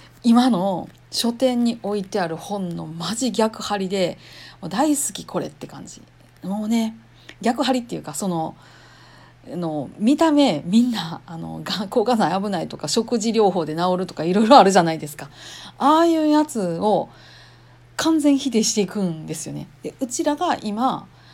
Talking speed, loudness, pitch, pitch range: 305 characters per minute, -21 LUFS, 210 Hz, 175-250 Hz